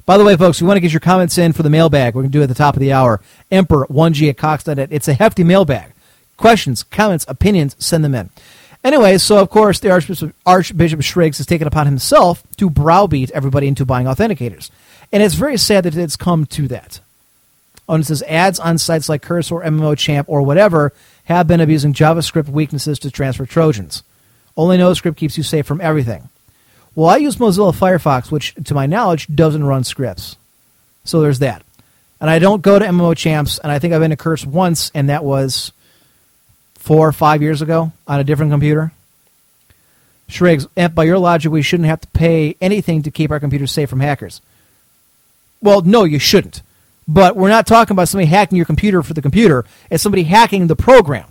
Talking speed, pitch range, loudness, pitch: 200 wpm, 140-175 Hz, -13 LUFS, 155 Hz